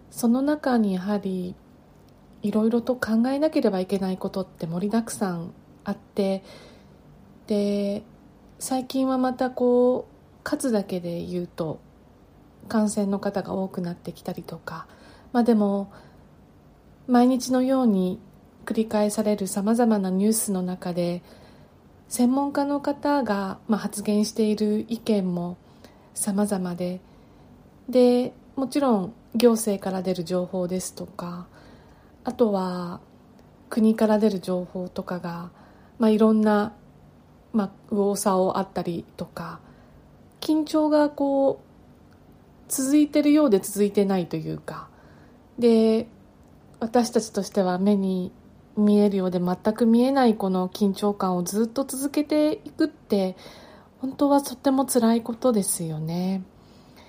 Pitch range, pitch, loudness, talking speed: 185-245 Hz, 210 Hz, -24 LUFS, 250 characters per minute